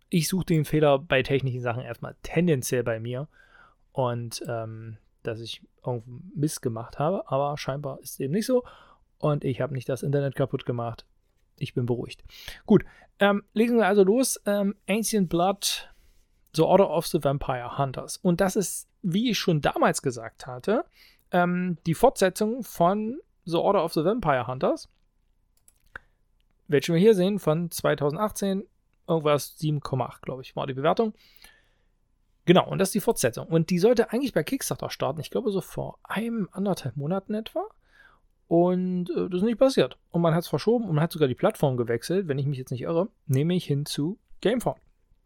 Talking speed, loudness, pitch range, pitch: 175 wpm, -26 LUFS, 135-195 Hz, 165 Hz